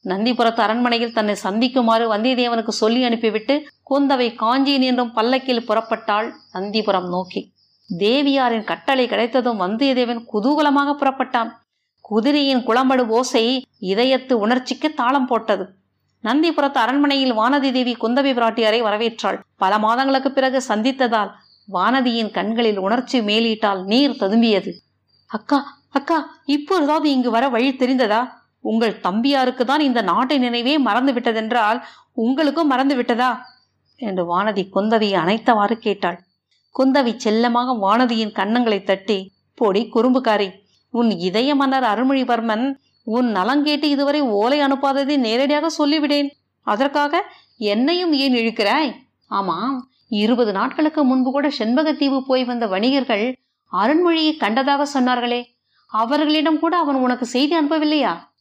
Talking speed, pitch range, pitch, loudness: 110 wpm, 220-275 Hz, 245 Hz, -19 LUFS